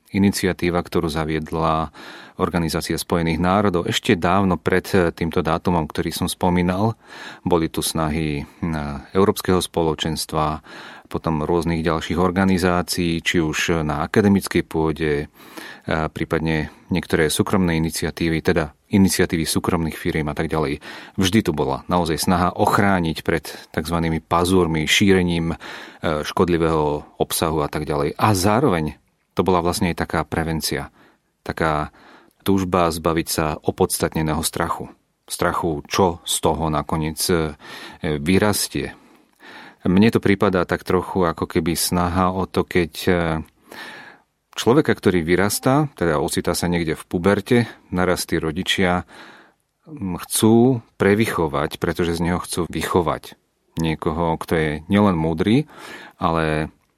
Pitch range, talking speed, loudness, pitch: 80-95 Hz, 115 wpm, -20 LUFS, 85 Hz